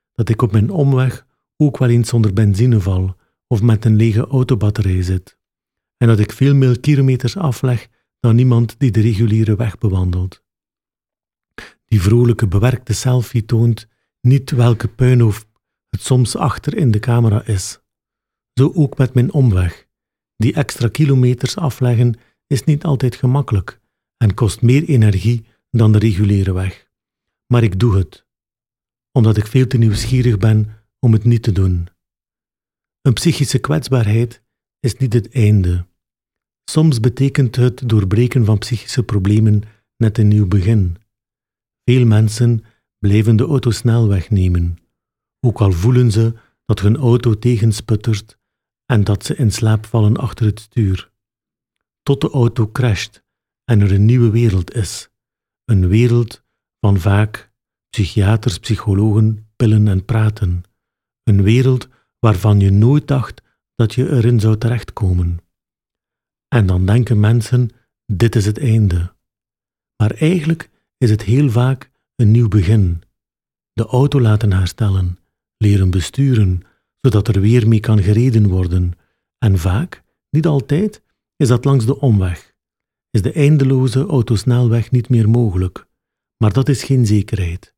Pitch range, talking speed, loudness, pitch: 105-125 Hz, 140 wpm, -15 LUFS, 115 Hz